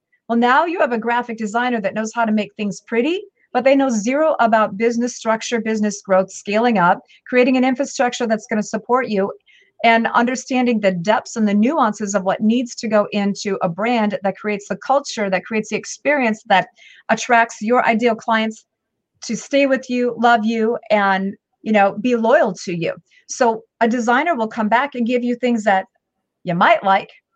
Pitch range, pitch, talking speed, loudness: 210-250 Hz, 230 Hz, 195 wpm, -18 LUFS